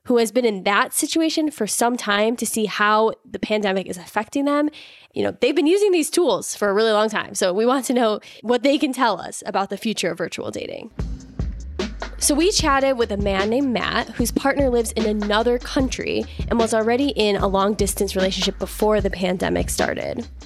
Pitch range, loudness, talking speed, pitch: 200-255 Hz, -21 LUFS, 205 wpm, 220 Hz